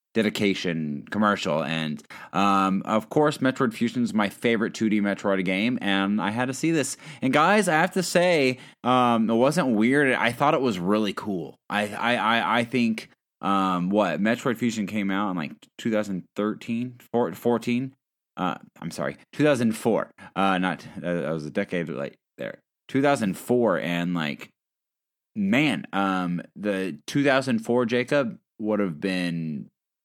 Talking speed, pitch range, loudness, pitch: 150 wpm, 95-125 Hz, -24 LUFS, 105 Hz